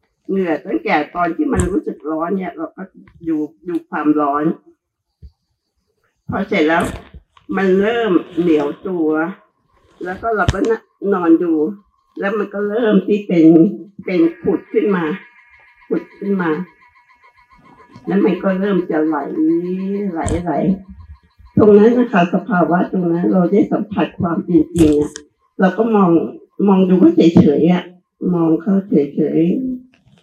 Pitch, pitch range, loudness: 175 Hz, 160-205 Hz, -16 LUFS